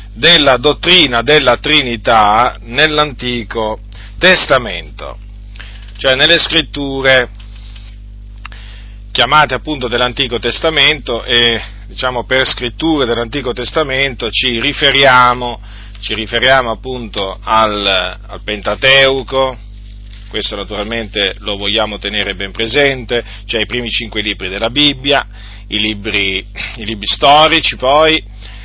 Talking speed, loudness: 100 wpm, -11 LUFS